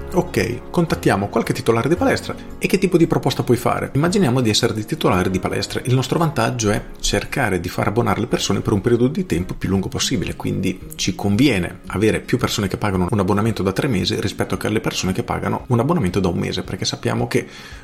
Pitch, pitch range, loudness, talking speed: 110 Hz, 95-130 Hz, -19 LUFS, 220 wpm